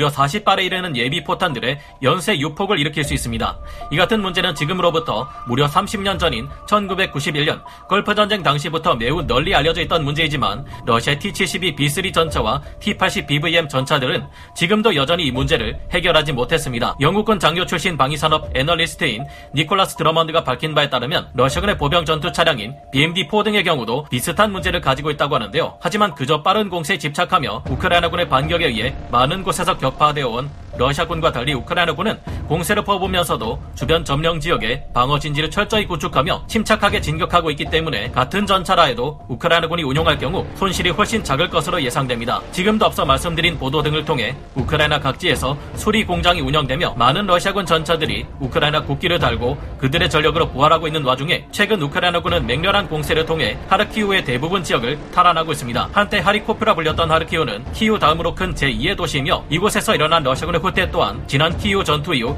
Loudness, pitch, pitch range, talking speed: -18 LUFS, 165 Hz, 145-185 Hz, 430 characters per minute